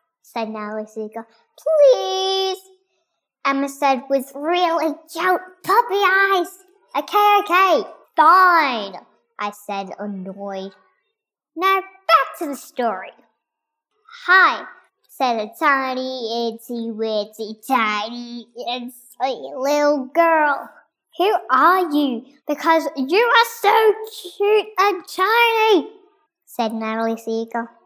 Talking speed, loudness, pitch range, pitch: 95 wpm, -18 LUFS, 235-375 Hz, 305 Hz